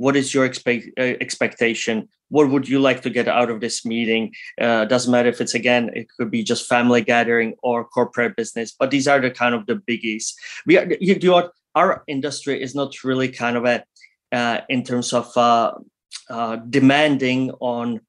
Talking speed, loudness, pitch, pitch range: 200 wpm, -19 LUFS, 125 Hz, 120-135 Hz